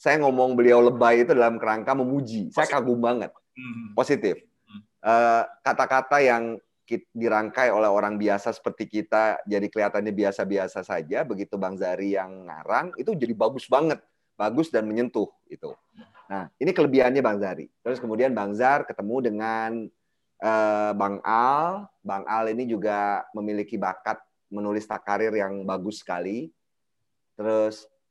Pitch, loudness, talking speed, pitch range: 110 Hz, -24 LUFS, 130 wpm, 105-120 Hz